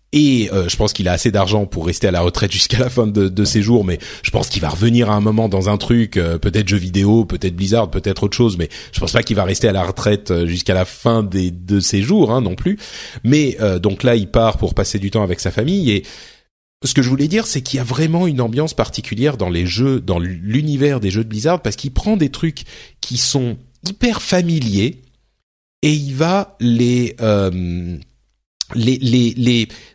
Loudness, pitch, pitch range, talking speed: -17 LUFS, 110 Hz, 95-130 Hz, 230 wpm